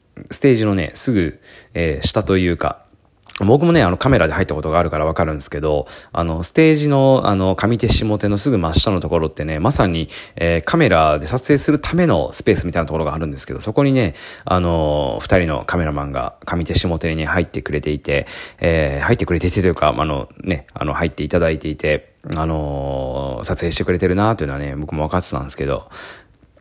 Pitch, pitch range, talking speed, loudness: 85 Hz, 75-100 Hz, 430 characters per minute, -18 LUFS